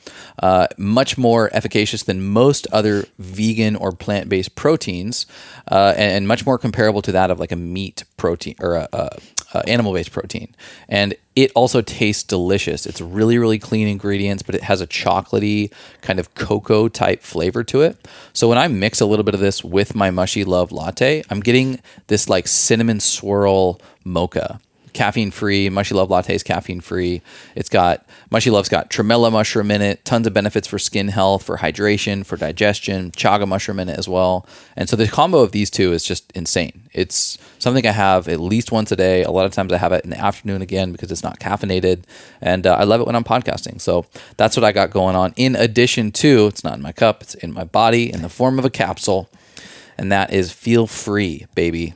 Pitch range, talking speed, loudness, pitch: 95-110 Hz, 205 wpm, -17 LUFS, 100 Hz